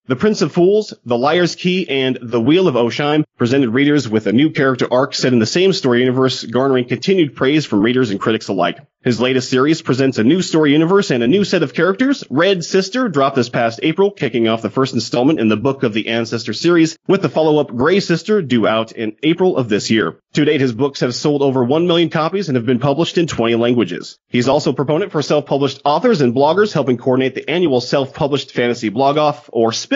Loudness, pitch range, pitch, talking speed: -15 LUFS, 120-160 Hz, 140 Hz, 230 wpm